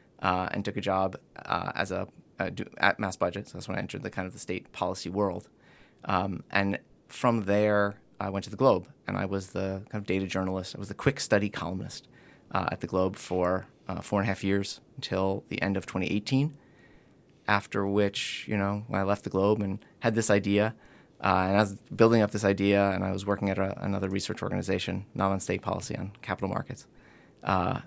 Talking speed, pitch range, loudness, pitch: 215 wpm, 95-105 Hz, -29 LUFS, 100 Hz